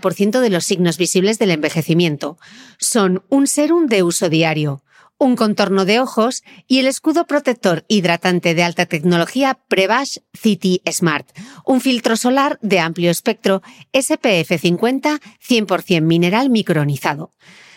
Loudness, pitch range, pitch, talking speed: -16 LUFS, 175-255 Hz, 195 Hz, 130 wpm